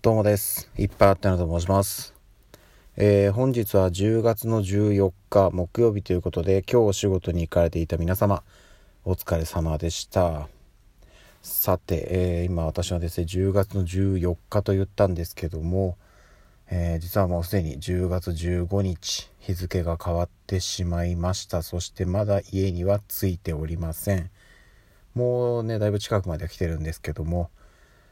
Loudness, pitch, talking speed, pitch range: -25 LUFS, 95 Hz, 275 characters per minute, 85-100 Hz